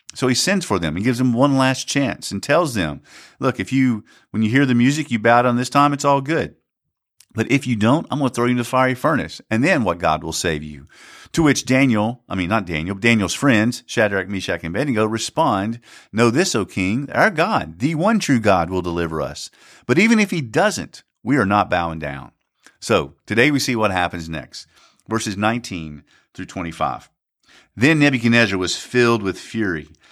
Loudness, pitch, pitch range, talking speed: -19 LUFS, 115 Hz, 95-135 Hz, 210 wpm